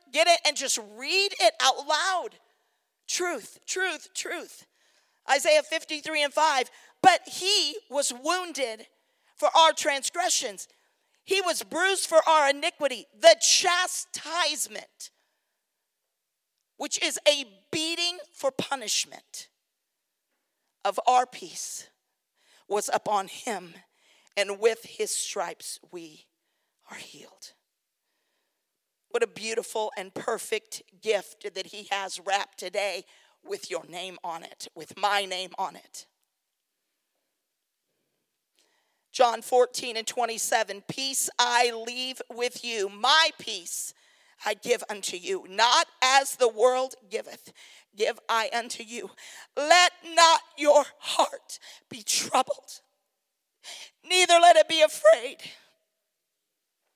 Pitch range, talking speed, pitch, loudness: 225-335 Hz, 110 wpm, 275 Hz, -25 LUFS